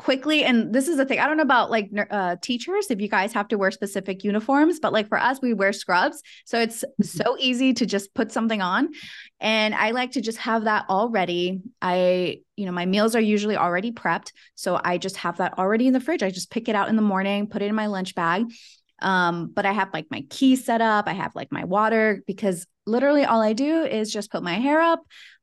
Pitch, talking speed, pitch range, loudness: 215 Hz, 240 wpm, 195-250 Hz, -23 LUFS